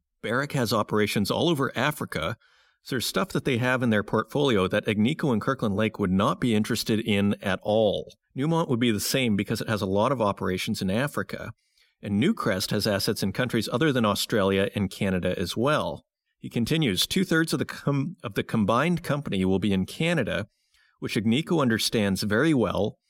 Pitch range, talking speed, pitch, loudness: 100-135 Hz, 190 wpm, 110 Hz, -25 LUFS